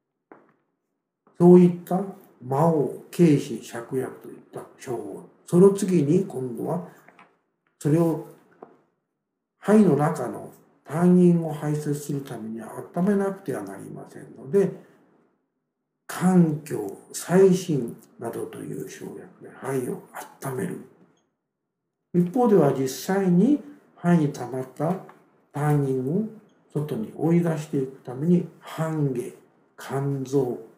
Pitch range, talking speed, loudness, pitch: 140-185 Hz, 170 characters per minute, -23 LUFS, 160 Hz